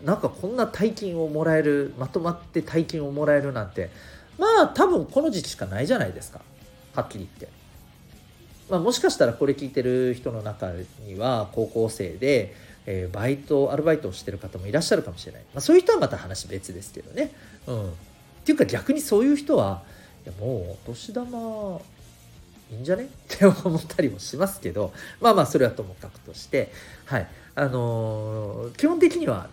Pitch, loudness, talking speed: 145 Hz, -24 LUFS, 380 characters per minute